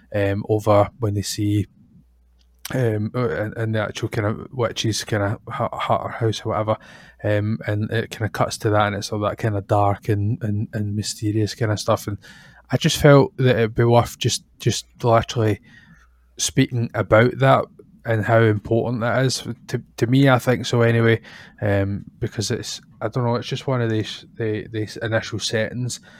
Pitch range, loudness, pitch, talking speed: 105-120 Hz, -21 LUFS, 110 Hz, 190 wpm